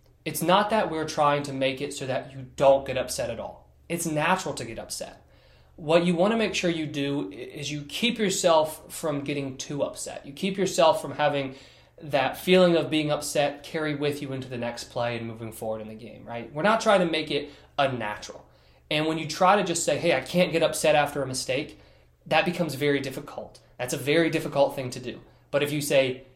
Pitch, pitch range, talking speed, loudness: 145 Hz, 130-160 Hz, 225 wpm, -26 LUFS